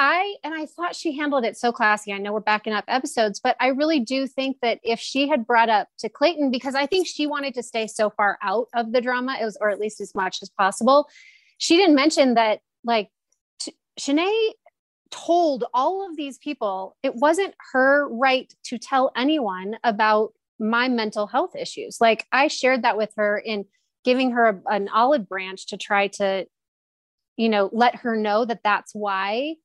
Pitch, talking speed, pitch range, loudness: 240 Hz, 200 wpm, 210-285 Hz, -22 LUFS